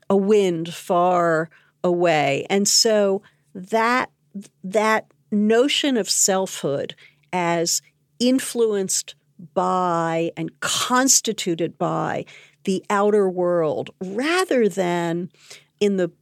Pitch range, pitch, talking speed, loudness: 170-210 Hz, 185 Hz, 90 wpm, -20 LUFS